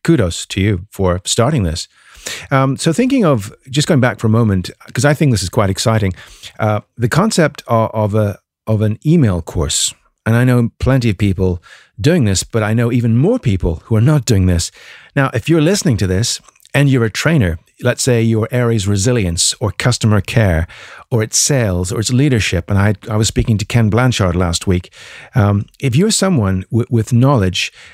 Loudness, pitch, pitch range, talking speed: -15 LUFS, 115 Hz, 100-130 Hz, 200 wpm